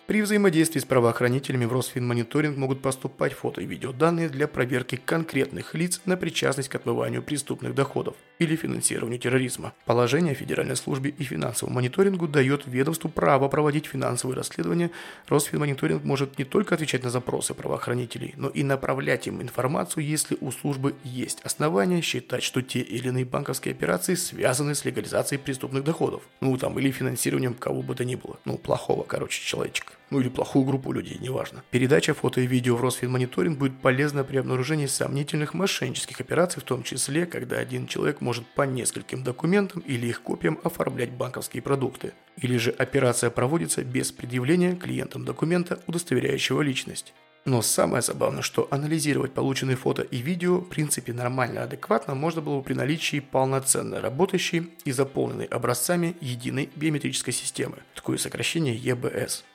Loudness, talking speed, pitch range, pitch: -26 LUFS, 155 wpm, 125-155 Hz, 135 Hz